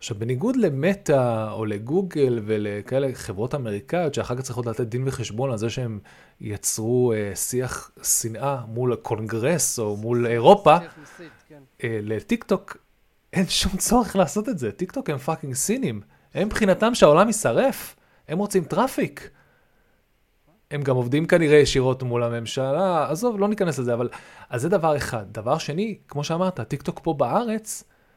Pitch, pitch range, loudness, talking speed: 140 Hz, 115-185 Hz, -23 LUFS, 145 wpm